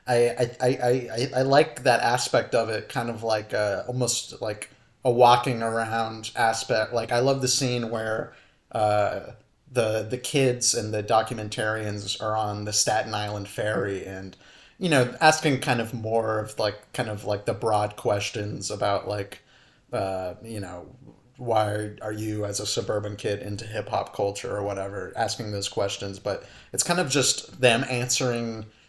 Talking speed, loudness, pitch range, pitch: 170 wpm, -25 LUFS, 105-125 Hz, 110 Hz